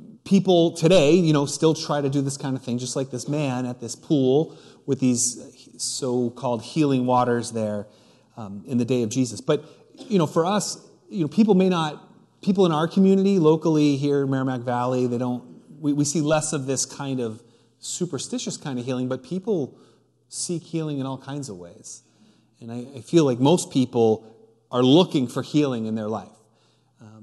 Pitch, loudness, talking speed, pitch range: 135 Hz, -23 LUFS, 190 wpm, 125-160 Hz